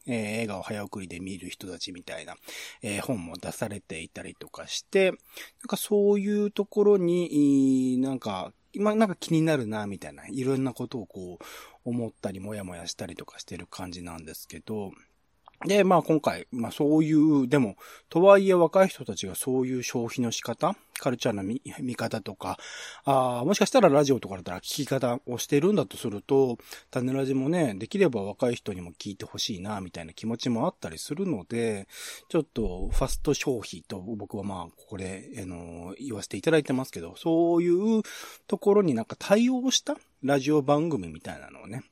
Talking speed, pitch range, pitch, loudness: 380 characters per minute, 100-165 Hz, 130 Hz, -27 LUFS